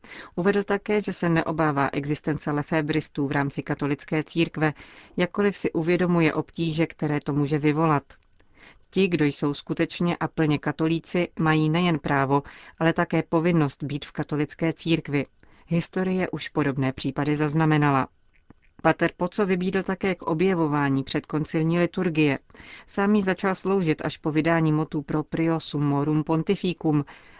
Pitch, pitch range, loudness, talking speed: 160 Hz, 150-170 Hz, -25 LUFS, 130 wpm